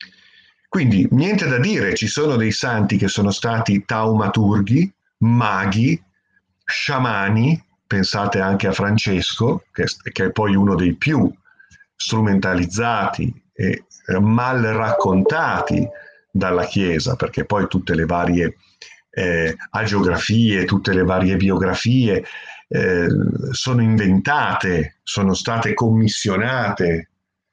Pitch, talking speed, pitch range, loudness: 105 Hz, 100 wpm, 95-120 Hz, -18 LUFS